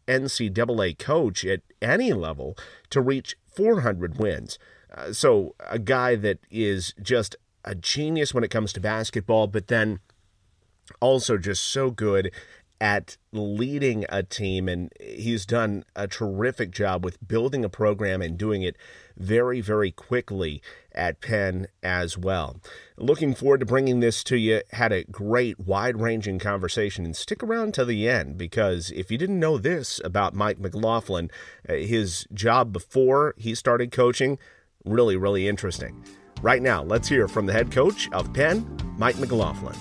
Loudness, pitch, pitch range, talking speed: -25 LUFS, 110 Hz, 95-125 Hz, 150 wpm